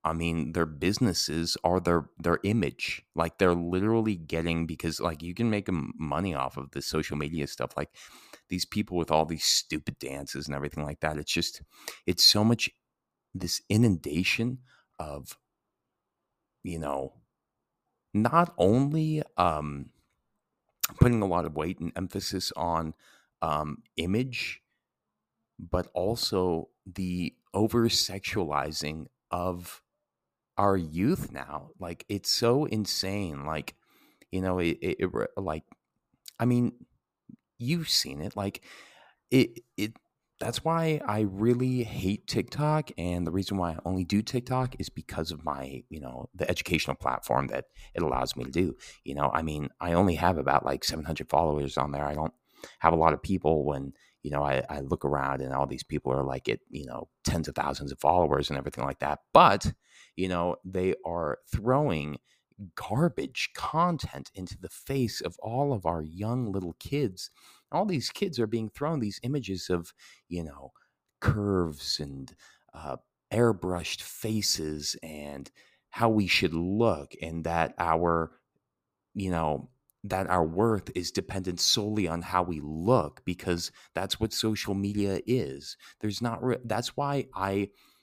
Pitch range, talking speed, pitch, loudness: 75-110 Hz, 155 wpm, 90 Hz, -29 LUFS